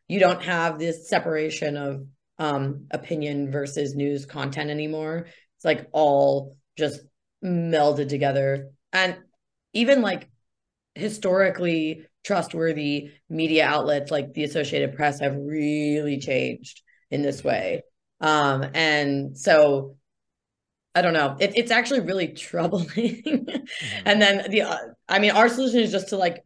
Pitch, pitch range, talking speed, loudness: 155 Hz, 145-185 Hz, 130 wpm, -23 LUFS